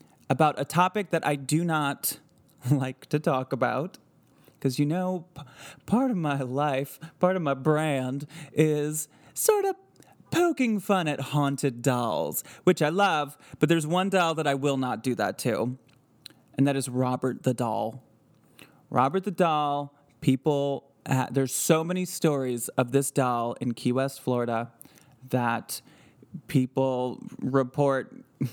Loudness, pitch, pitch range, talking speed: -27 LUFS, 140 Hz, 130-160 Hz, 145 wpm